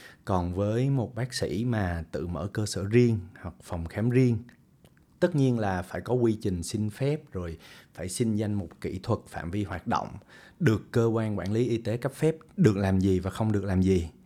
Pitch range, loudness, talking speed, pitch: 95-120 Hz, -28 LUFS, 220 wpm, 105 Hz